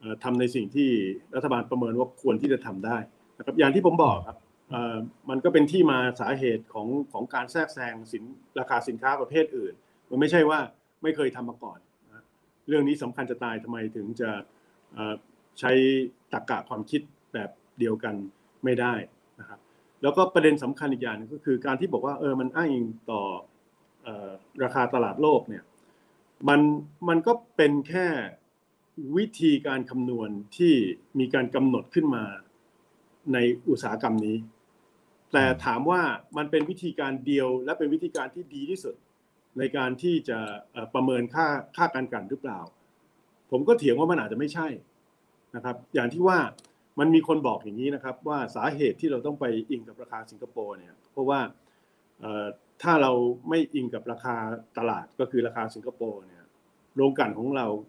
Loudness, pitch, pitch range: -27 LUFS, 130 Hz, 120-150 Hz